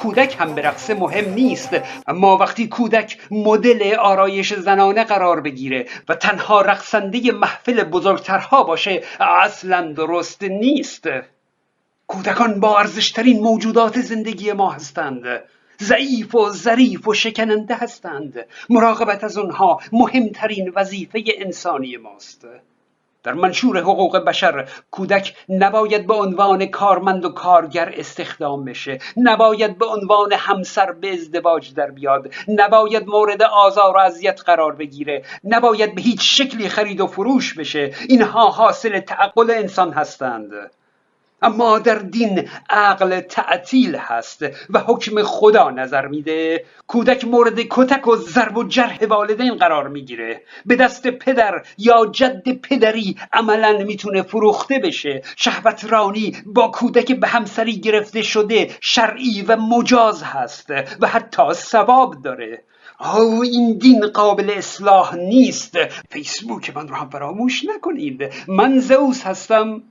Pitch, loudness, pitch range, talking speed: 210 Hz, -16 LUFS, 185-230 Hz, 125 wpm